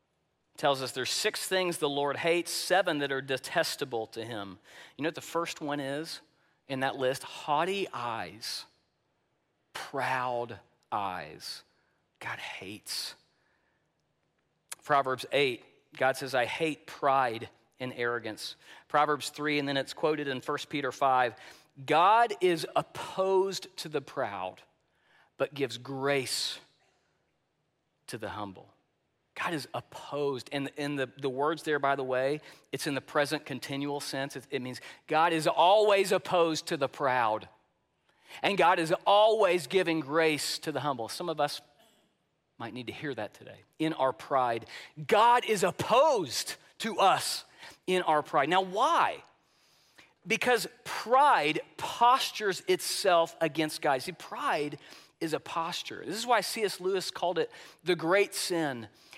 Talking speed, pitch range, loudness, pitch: 140 wpm, 135-180 Hz, -30 LUFS, 150 Hz